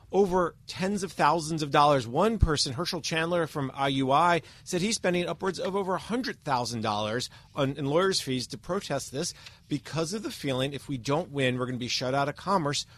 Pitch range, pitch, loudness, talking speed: 135-175 Hz, 145 Hz, -28 LUFS, 205 wpm